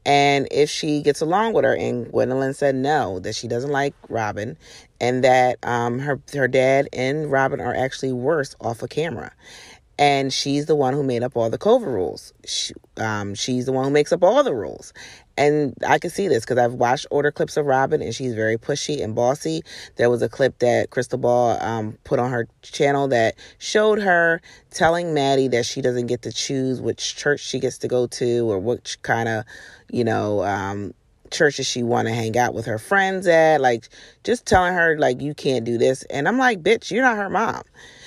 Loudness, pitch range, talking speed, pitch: -21 LUFS, 120-145 Hz, 215 wpm, 130 Hz